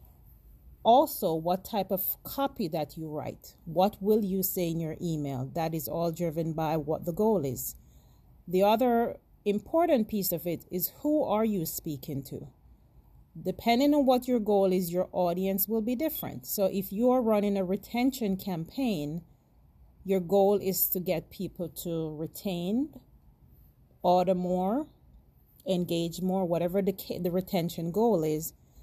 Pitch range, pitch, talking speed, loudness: 165-210 Hz, 185 Hz, 150 wpm, -29 LUFS